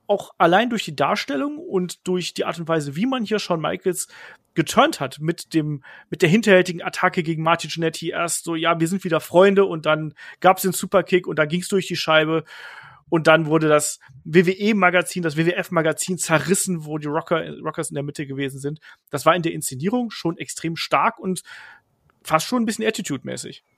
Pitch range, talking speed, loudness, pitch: 155-185 Hz, 190 wpm, -21 LUFS, 170 Hz